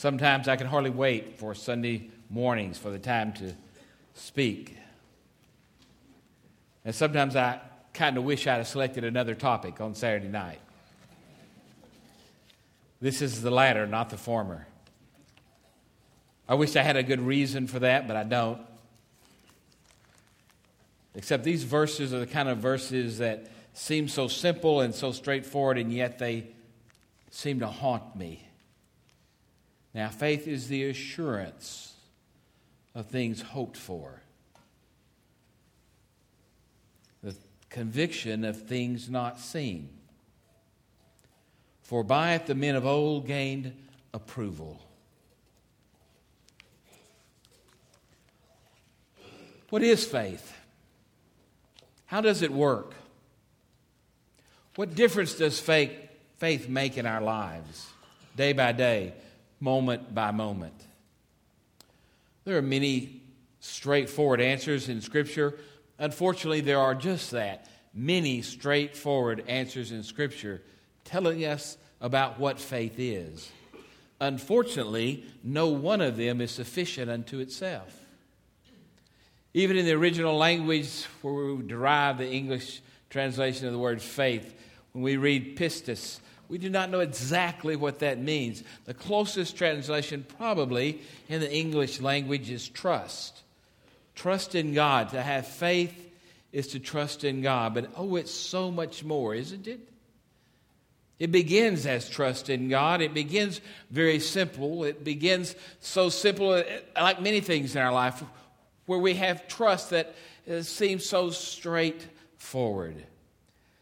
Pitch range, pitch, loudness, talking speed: 120-155 Hz, 135 Hz, -28 LUFS, 120 wpm